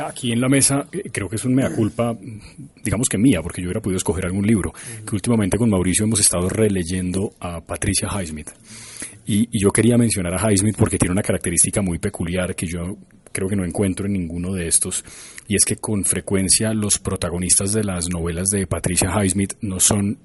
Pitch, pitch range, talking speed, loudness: 100 Hz, 90-110 Hz, 200 wpm, -19 LUFS